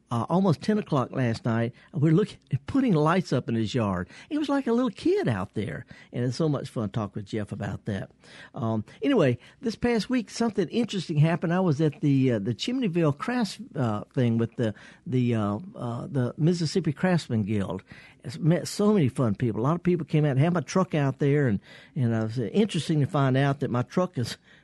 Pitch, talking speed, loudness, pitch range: 140 Hz, 225 wpm, -26 LUFS, 120-180 Hz